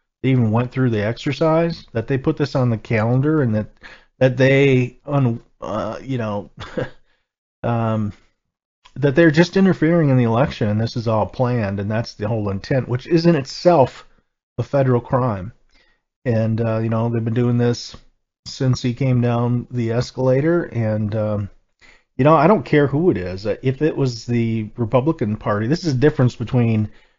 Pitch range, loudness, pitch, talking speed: 115-140 Hz, -19 LUFS, 125 Hz, 175 wpm